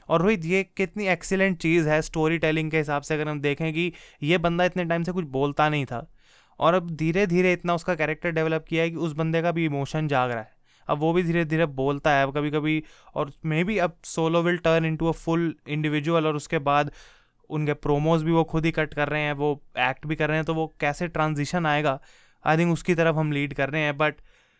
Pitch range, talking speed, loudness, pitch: 150-170 Hz, 240 wpm, -25 LUFS, 160 Hz